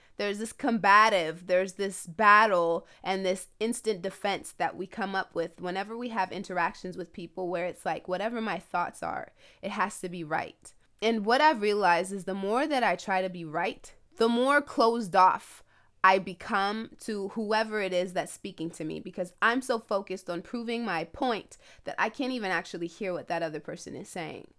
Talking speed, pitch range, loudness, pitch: 195 wpm, 180-220 Hz, -28 LUFS, 195 Hz